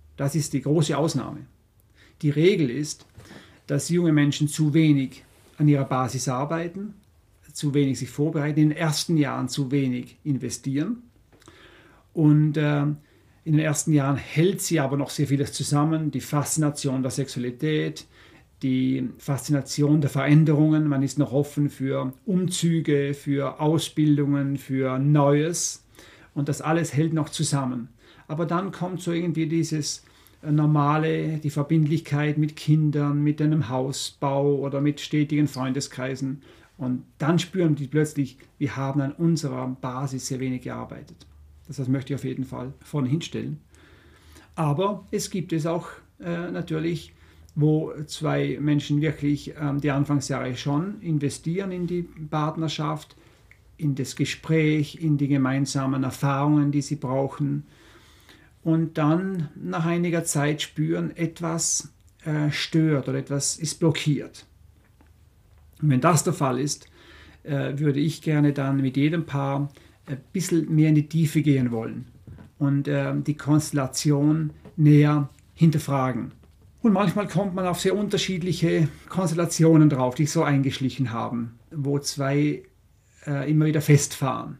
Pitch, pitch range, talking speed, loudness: 145 Hz, 135-155 Hz, 140 wpm, -24 LUFS